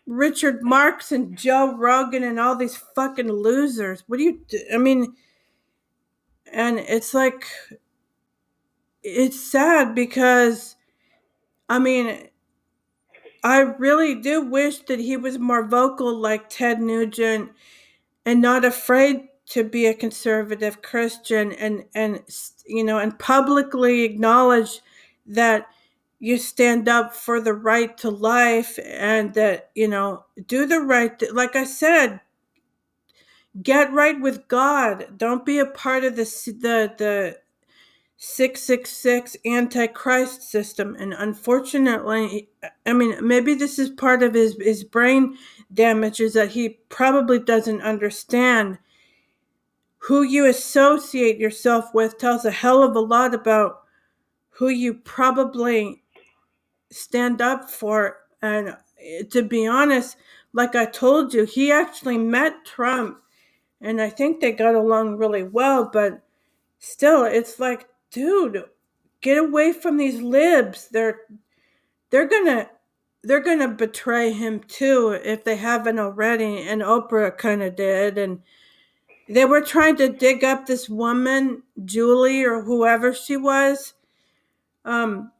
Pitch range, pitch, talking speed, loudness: 225-265 Hz, 245 Hz, 135 wpm, -20 LUFS